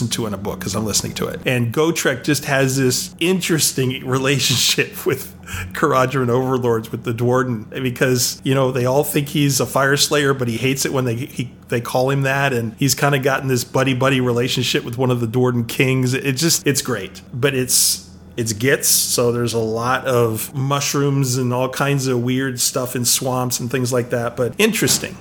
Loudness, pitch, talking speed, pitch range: -18 LUFS, 130 Hz, 205 wpm, 120-140 Hz